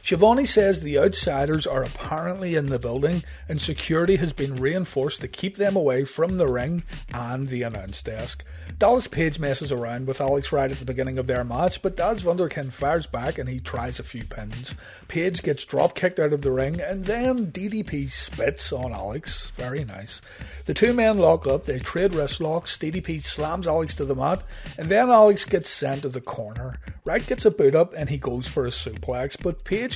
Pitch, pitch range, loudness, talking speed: 150 Hz, 130-180 Hz, -24 LUFS, 200 wpm